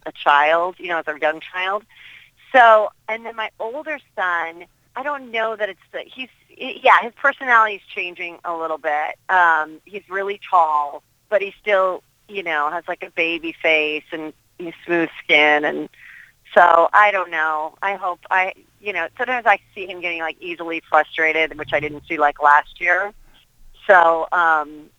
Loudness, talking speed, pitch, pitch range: -18 LUFS, 175 wpm, 170 Hz, 155-200 Hz